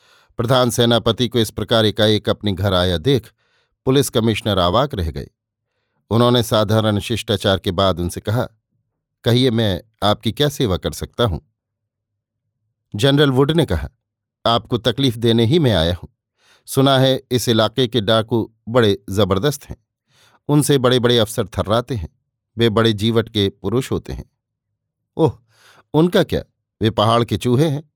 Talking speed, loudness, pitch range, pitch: 150 wpm, -18 LUFS, 105-125 Hz, 115 Hz